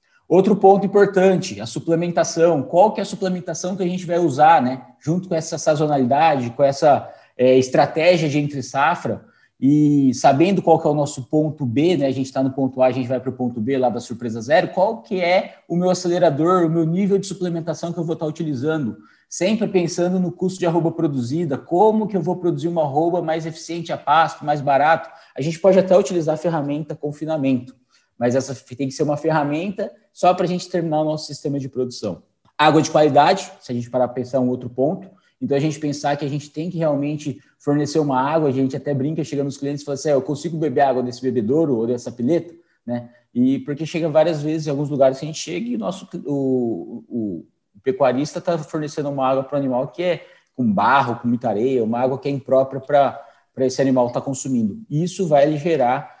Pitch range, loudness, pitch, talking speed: 135-170 Hz, -20 LUFS, 155 Hz, 225 wpm